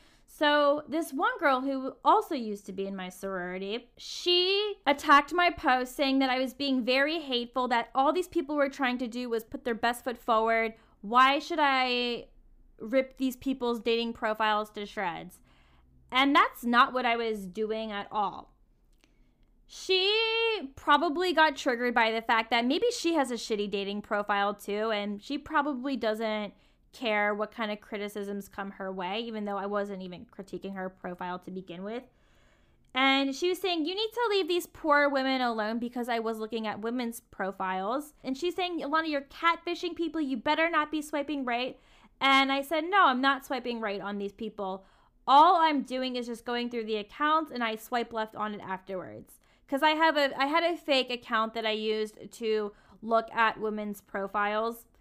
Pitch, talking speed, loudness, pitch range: 245 Hz, 190 wpm, -28 LUFS, 215-285 Hz